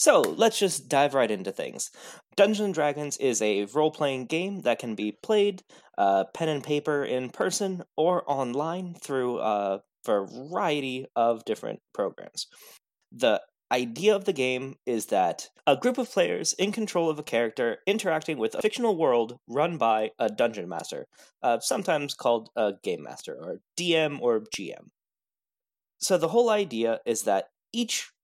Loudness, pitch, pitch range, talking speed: -27 LUFS, 155 Hz, 125-200 Hz, 160 wpm